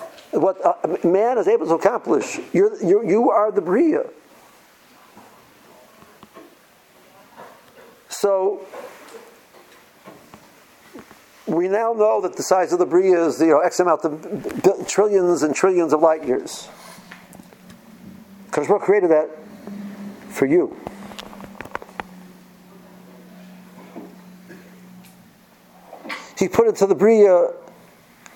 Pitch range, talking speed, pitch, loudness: 185-215 Hz, 100 wpm, 195 Hz, -18 LUFS